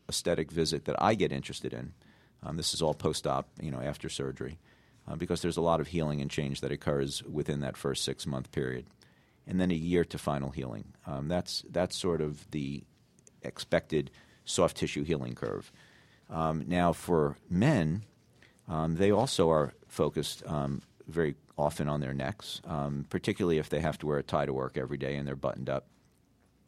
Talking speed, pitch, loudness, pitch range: 185 wpm, 75 Hz, -32 LUFS, 70-85 Hz